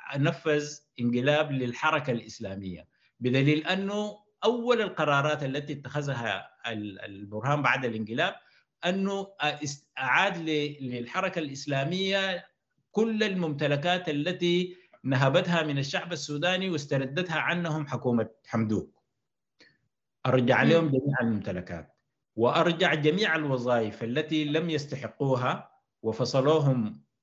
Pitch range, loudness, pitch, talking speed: 125-170 Hz, -28 LUFS, 150 Hz, 85 wpm